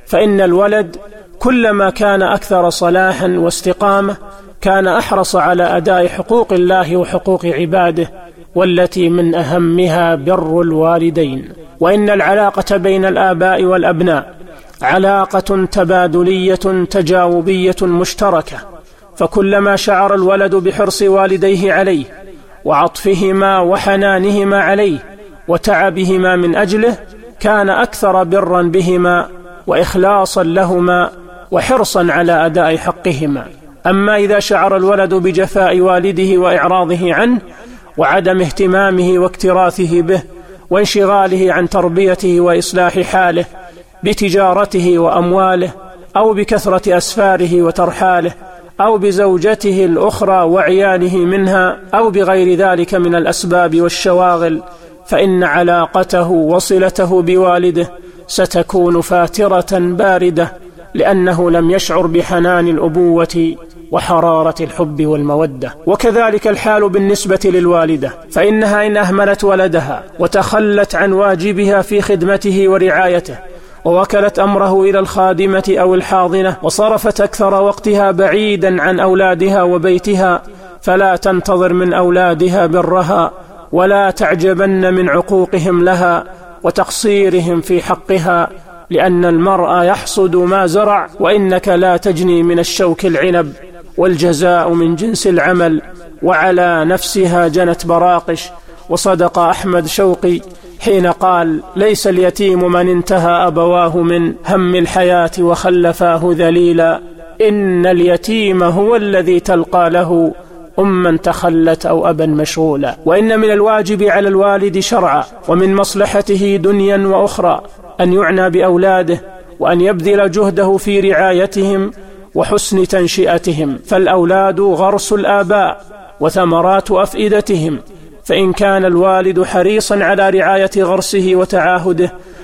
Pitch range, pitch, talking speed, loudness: 175-195 Hz, 185 Hz, 100 wpm, -11 LUFS